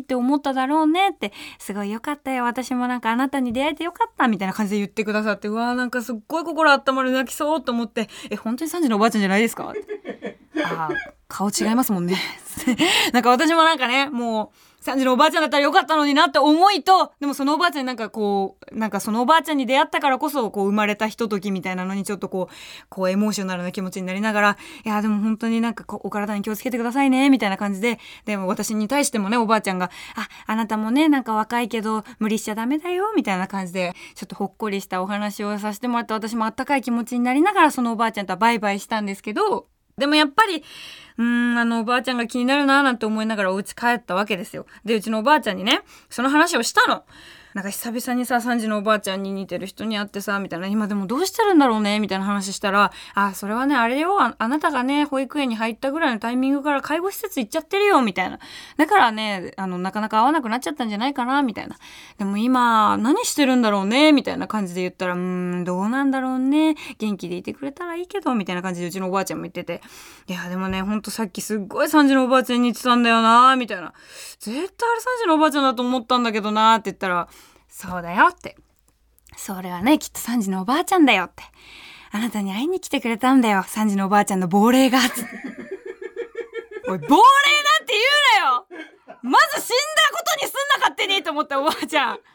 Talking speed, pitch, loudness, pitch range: 495 characters per minute, 240 Hz, -20 LUFS, 205-290 Hz